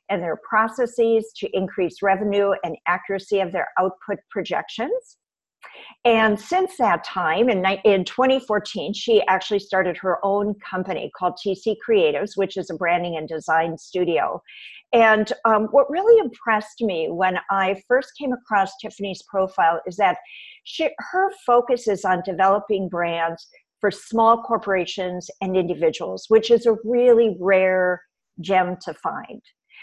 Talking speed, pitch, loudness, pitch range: 140 wpm, 200 Hz, -21 LUFS, 185-235 Hz